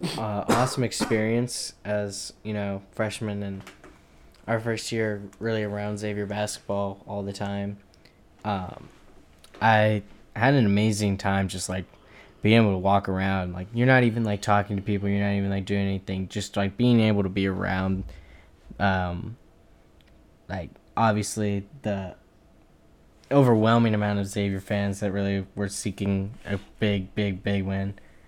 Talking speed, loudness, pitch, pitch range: 150 wpm, -26 LUFS, 100 Hz, 95-110 Hz